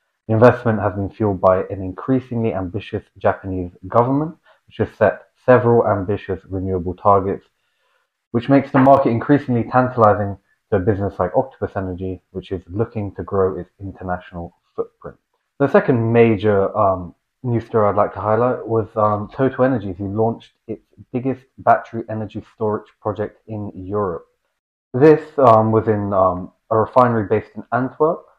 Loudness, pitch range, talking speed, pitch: -18 LUFS, 95-125 Hz, 150 wpm, 105 Hz